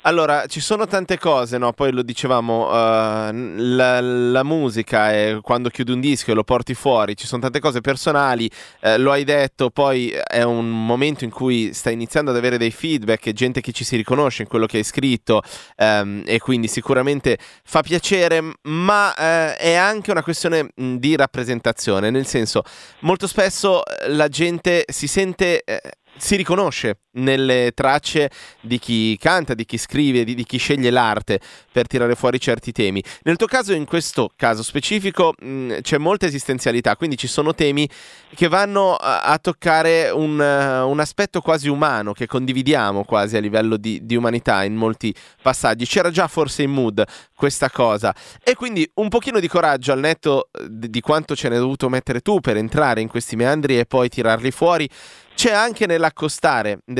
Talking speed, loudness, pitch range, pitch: 180 wpm, -19 LUFS, 120-160 Hz, 130 Hz